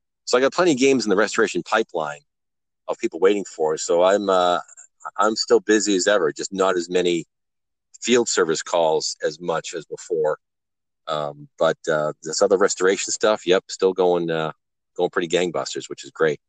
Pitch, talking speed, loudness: 105 Hz, 185 wpm, -21 LUFS